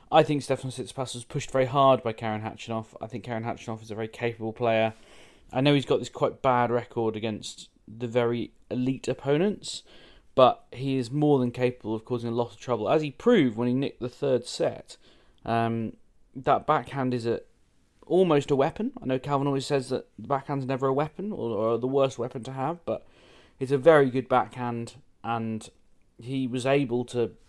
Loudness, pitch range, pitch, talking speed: -27 LUFS, 115-140 Hz, 125 Hz, 200 wpm